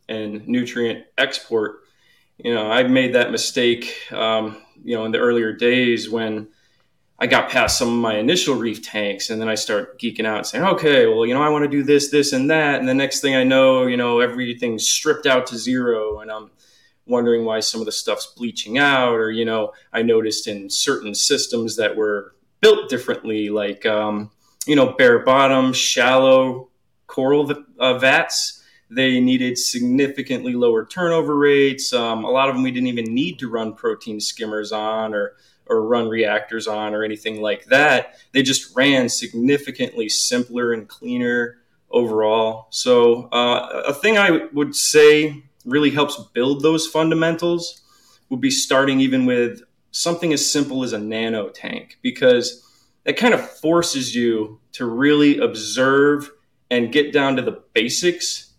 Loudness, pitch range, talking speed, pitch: -18 LUFS, 115-145 Hz, 170 wpm, 125 Hz